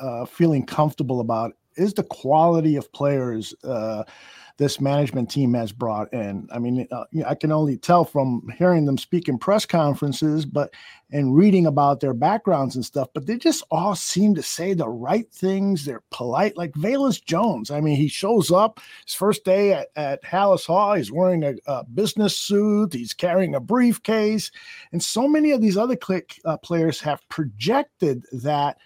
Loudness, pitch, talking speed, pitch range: -22 LUFS, 160 Hz, 185 wpm, 140-200 Hz